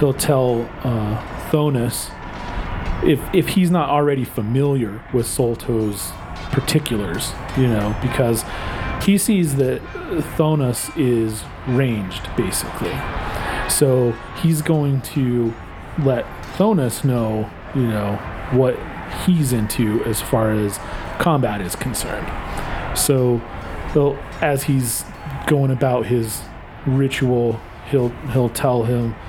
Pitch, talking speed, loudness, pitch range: 120 Hz, 110 wpm, -20 LUFS, 110-140 Hz